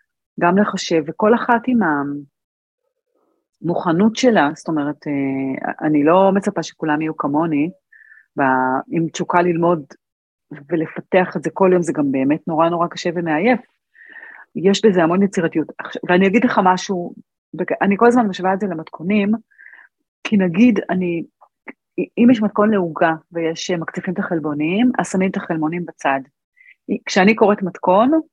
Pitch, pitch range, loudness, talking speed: 180 Hz, 160-210 Hz, -18 LUFS, 140 wpm